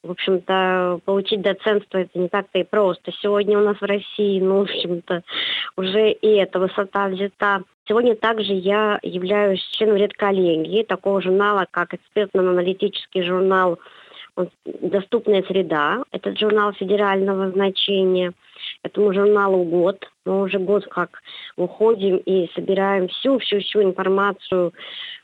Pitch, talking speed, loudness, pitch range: 195 Hz, 120 wpm, -20 LUFS, 185-205 Hz